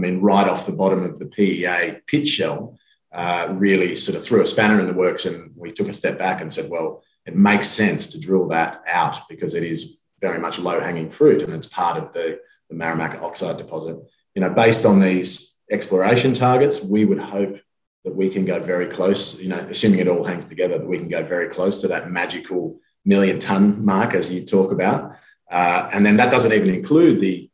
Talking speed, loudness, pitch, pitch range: 220 wpm, -19 LUFS, 95 Hz, 90-105 Hz